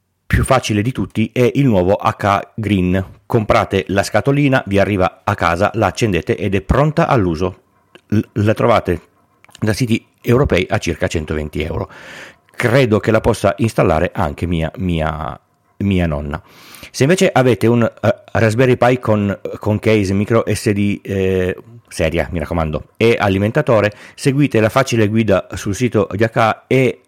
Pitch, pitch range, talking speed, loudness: 105 Hz, 95-115 Hz, 150 wpm, -16 LUFS